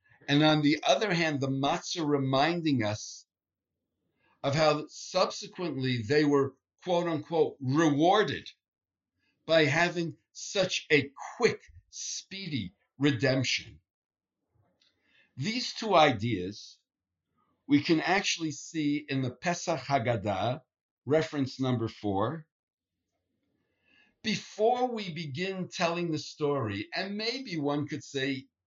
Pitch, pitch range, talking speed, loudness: 145 Hz, 125-170 Hz, 105 wpm, -29 LUFS